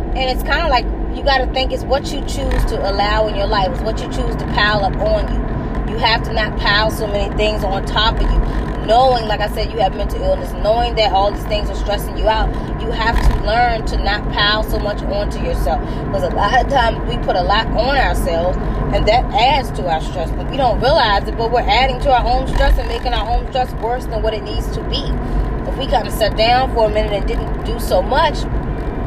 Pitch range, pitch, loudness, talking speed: 195-240 Hz, 210 Hz, -17 LUFS, 250 wpm